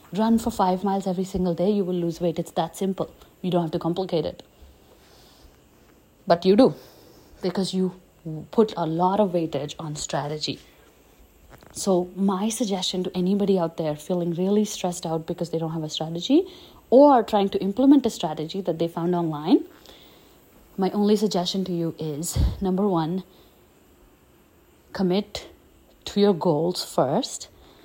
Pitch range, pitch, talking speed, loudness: 165-200 Hz, 185 Hz, 155 wpm, -24 LUFS